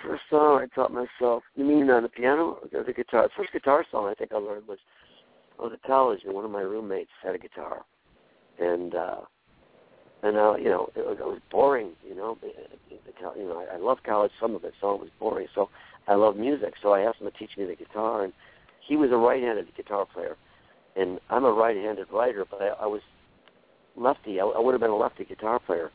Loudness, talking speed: -26 LUFS, 225 wpm